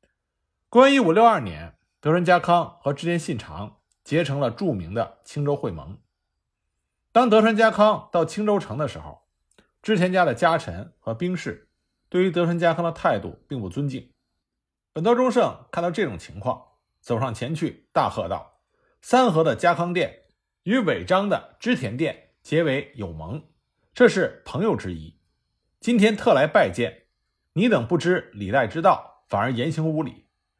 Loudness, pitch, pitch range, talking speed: -22 LUFS, 160 Hz, 115-190 Hz, 235 characters per minute